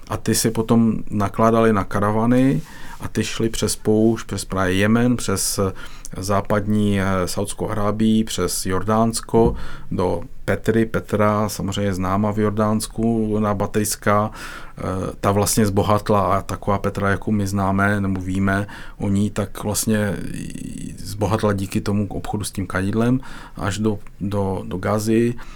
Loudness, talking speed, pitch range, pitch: -21 LUFS, 145 wpm, 100-110 Hz, 105 Hz